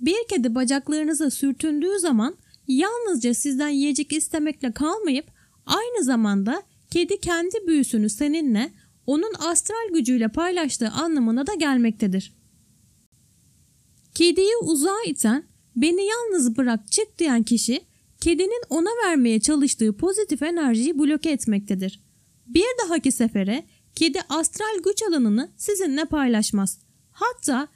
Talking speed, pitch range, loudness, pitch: 110 wpm, 250-350 Hz, -22 LUFS, 300 Hz